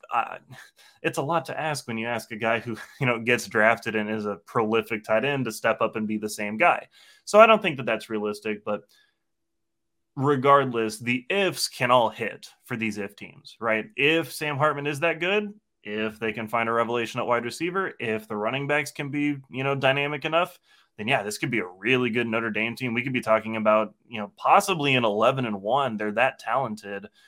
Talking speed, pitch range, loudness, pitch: 220 wpm, 110-145 Hz, -25 LUFS, 120 Hz